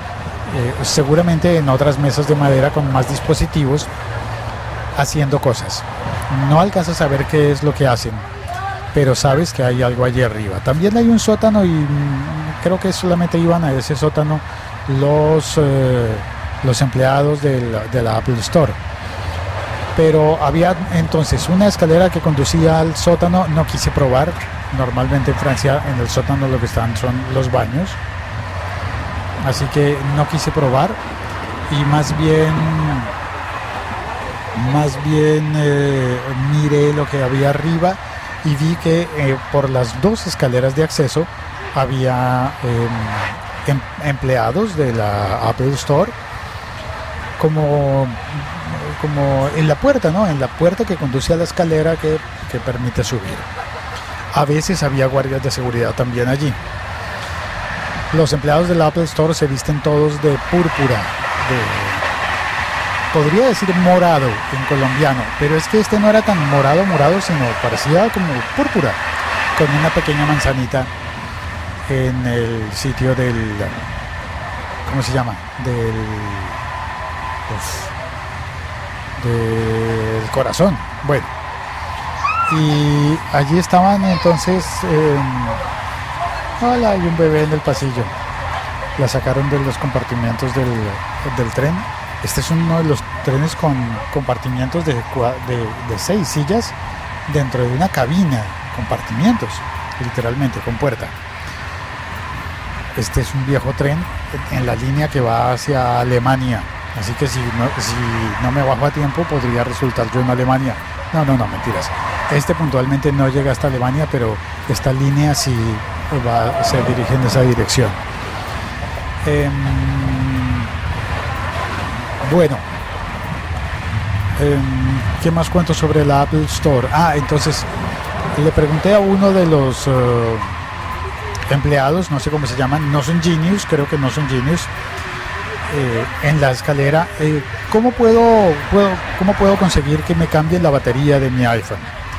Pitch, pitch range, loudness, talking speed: 130 Hz, 110-150 Hz, -17 LUFS, 135 wpm